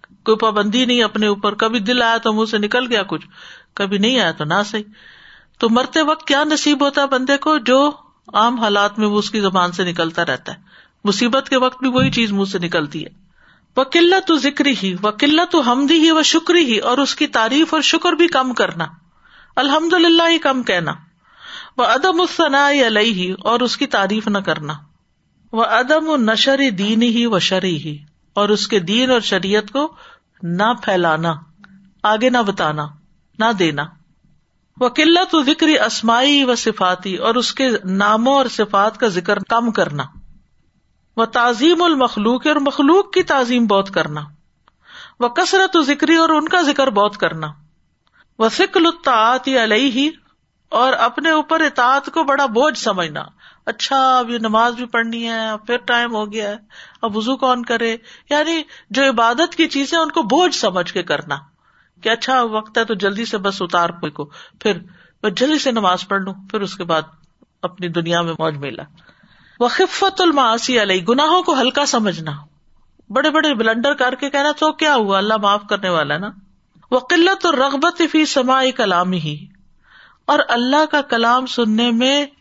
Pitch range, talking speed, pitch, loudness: 200-285 Hz, 175 wpm, 235 Hz, -16 LUFS